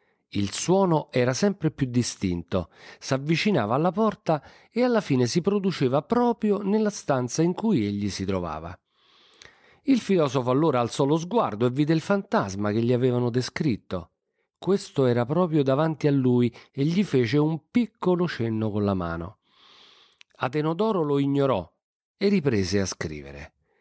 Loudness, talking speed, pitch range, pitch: -25 LUFS, 145 wpm, 120-195 Hz, 145 Hz